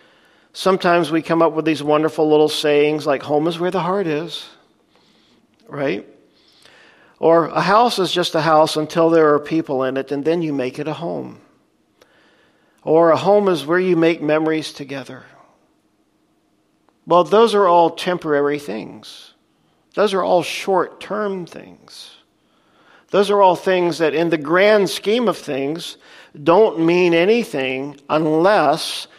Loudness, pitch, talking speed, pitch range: -17 LUFS, 165 Hz, 150 wpm, 150-180 Hz